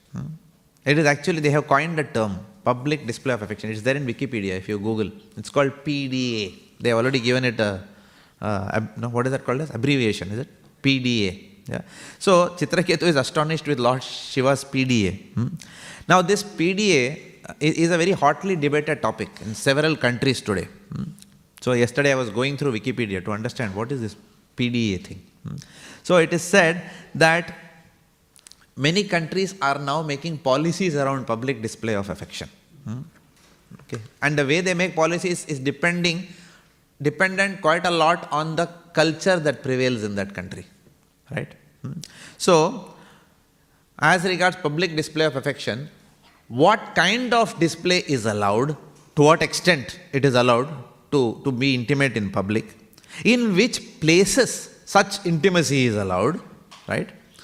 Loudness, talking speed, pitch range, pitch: -22 LUFS, 160 wpm, 120-170 Hz, 145 Hz